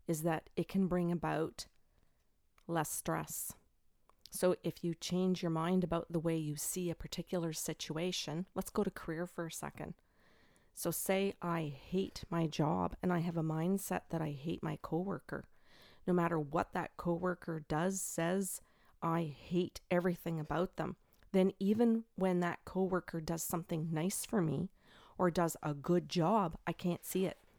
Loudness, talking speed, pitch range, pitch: -37 LUFS, 165 wpm, 165-185 Hz, 175 Hz